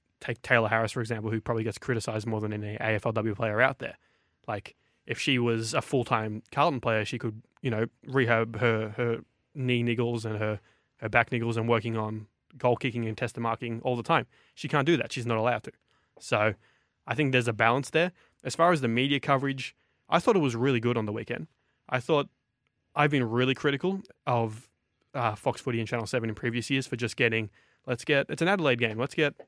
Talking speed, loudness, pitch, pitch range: 220 wpm, -28 LUFS, 120 Hz, 115-130 Hz